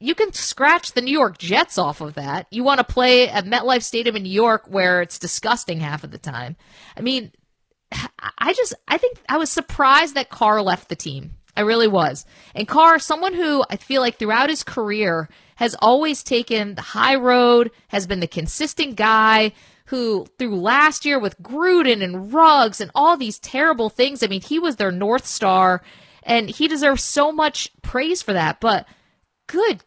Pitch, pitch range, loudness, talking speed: 235 Hz, 200-285 Hz, -18 LUFS, 190 wpm